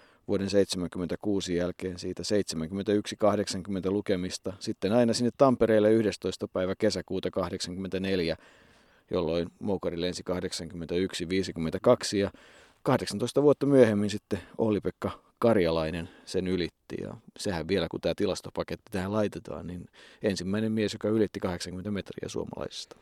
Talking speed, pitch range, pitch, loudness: 115 wpm, 90-105 Hz, 95 Hz, -29 LUFS